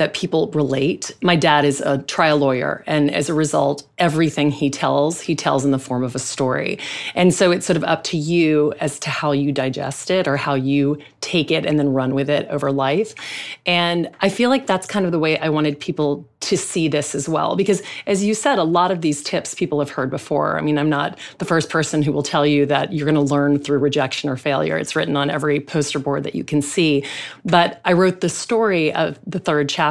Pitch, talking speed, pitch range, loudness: 150 Hz, 240 wpm, 145-170 Hz, -19 LUFS